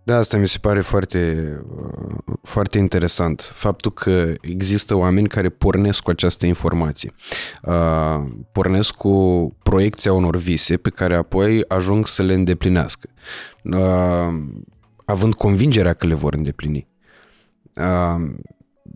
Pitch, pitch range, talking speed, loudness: 90 Hz, 85-100 Hz, 120 wpm, -19 LUFS